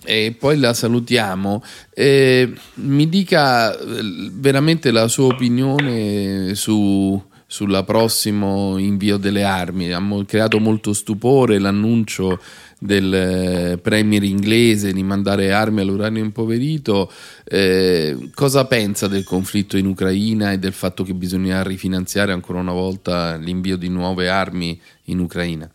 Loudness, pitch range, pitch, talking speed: -18 LUFS, 95-110 Hz, 100 Hz, 120 wpm